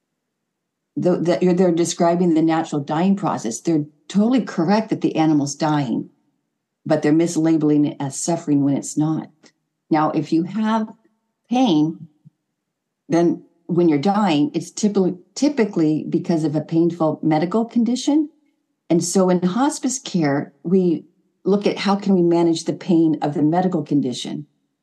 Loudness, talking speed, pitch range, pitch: -19 LUFS, 145 wpm, 155-195 Hz, 170 Hz